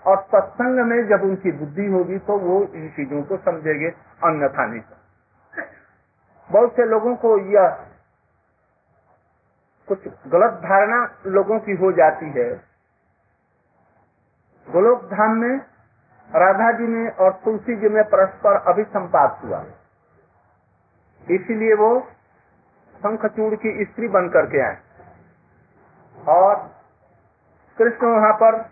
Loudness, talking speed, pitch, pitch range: -19 LUFS, 115 wpm, 205 Hz, 170-225 Hz